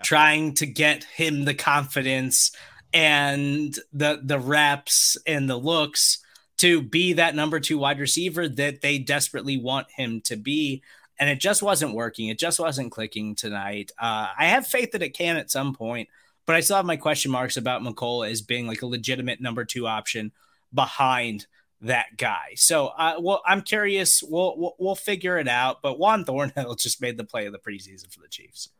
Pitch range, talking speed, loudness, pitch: 125-165 Hz, 190 wpm, -23 LUFS, 145 Hz